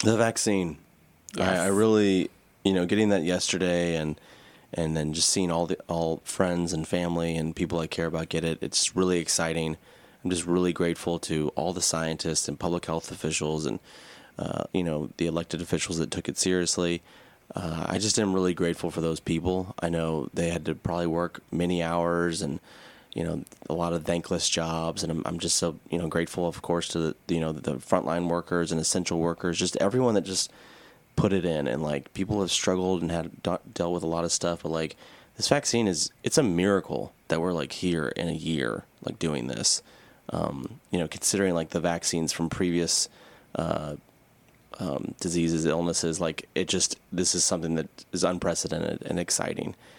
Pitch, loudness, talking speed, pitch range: 85 Hz, -27 LUFS, 195 wpm, 80-90 Hz